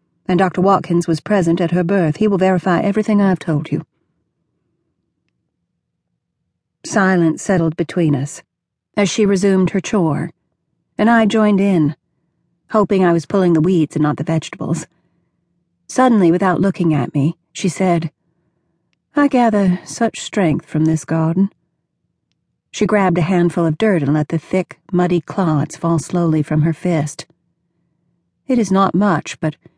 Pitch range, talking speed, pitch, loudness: 160-195 Hz, 150 wpm, 175 Hz, -16 LUFS